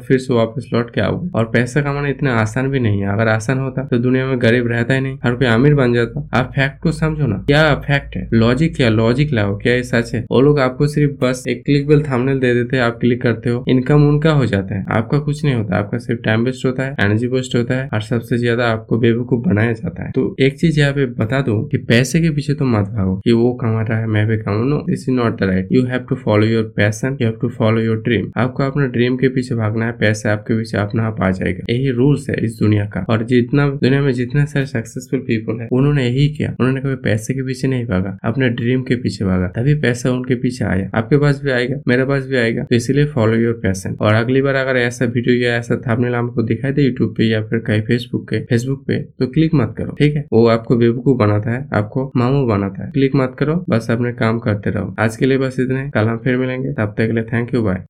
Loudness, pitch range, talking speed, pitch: -17 LUFS, 110-135 Hz, 255 wpm, 120 Hz